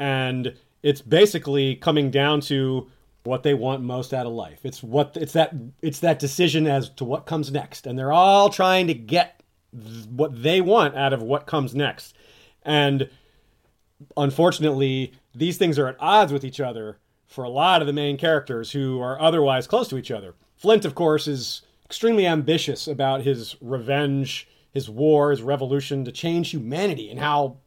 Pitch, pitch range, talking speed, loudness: 140 Hz, 130-155 Hz, 180 wpm, -22 LUFS